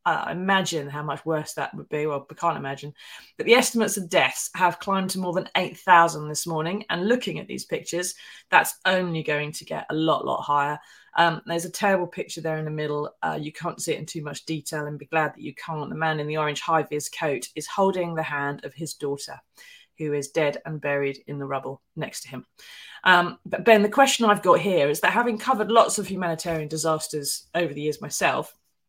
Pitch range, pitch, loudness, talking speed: 150-185 Hz, 160 Hz, -24 LUFS, 230 wpm